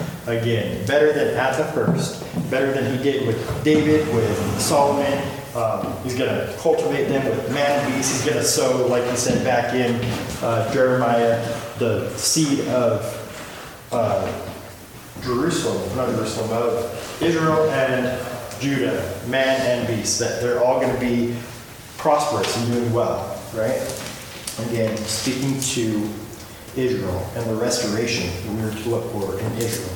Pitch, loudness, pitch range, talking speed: 120 Hz, -21 LUFS, 115-135 Hz, 145 wpm